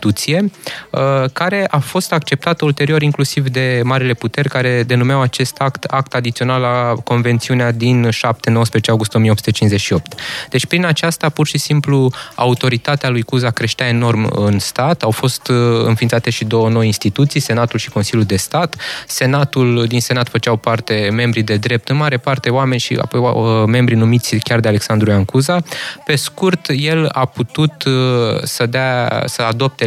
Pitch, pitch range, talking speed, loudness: 125 Hz, 115-140 Hz, 155 wpm, -15 LUFS